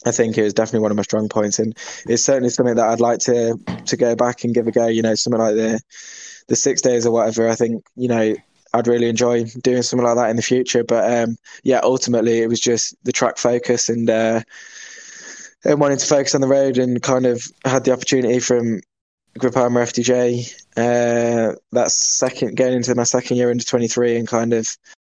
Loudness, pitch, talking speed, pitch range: -18 LUFS, 120 Hz, 215 wpm, 115-125 Hz